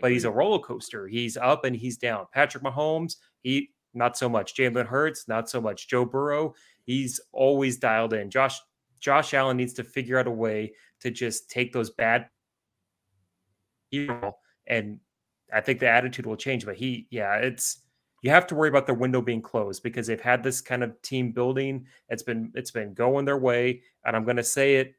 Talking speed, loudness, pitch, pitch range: 195 wpm, -26 LUFS, 125 Hz, 115-135 Hz